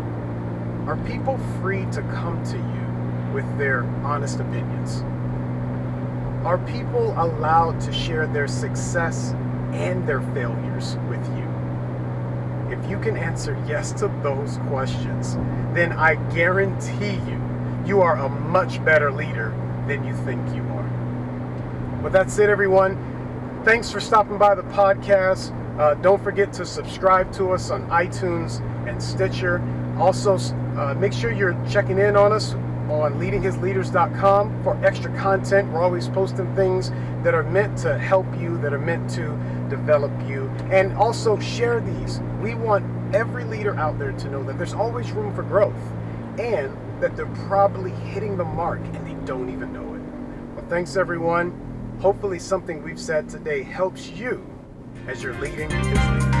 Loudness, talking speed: -23 LUFS, 150 wpm